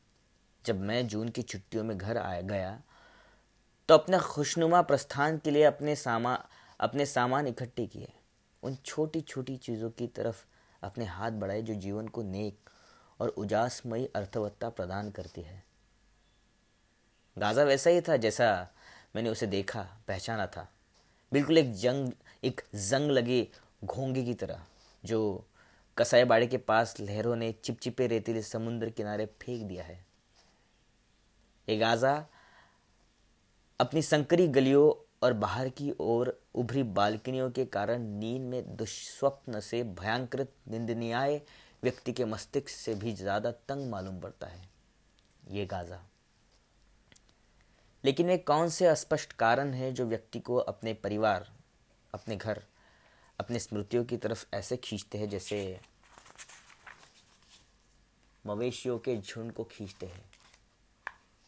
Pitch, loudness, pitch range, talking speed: 115 Hz, -31 LUFS, 105-130 Hz, 130 wpm